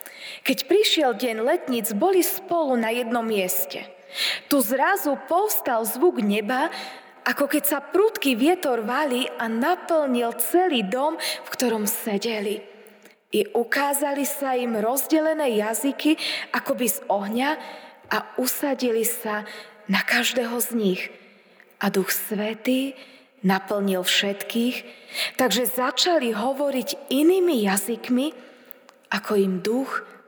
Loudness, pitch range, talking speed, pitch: -23 LUFS, 220-285 Hz, 115 wpm, 250 Hz